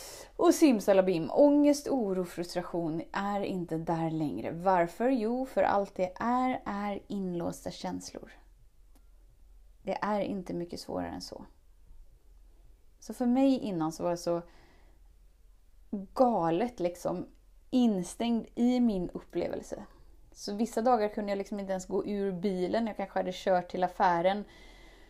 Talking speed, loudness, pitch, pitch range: 135 wpm, -30 LUFS, 190 Hz, 165-225 Hz